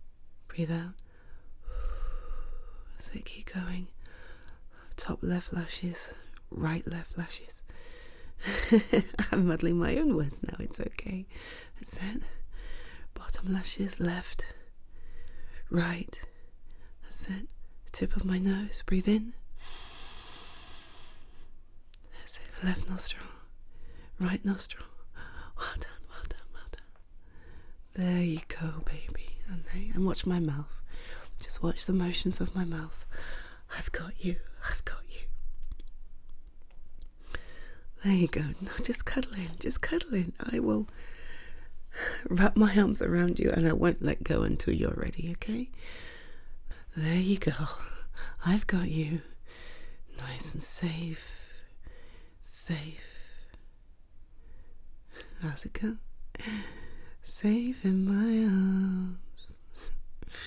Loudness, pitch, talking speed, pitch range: -31 LUFS, 180 Hz, 110 wpm, 160-195 Hz